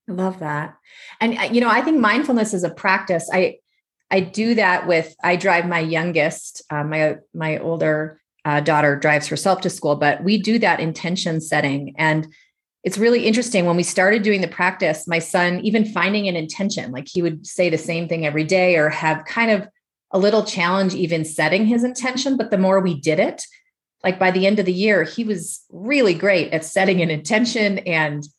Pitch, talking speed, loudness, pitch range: 180 Hz, 200 wpm, -19 LUFS, 160-210 Hz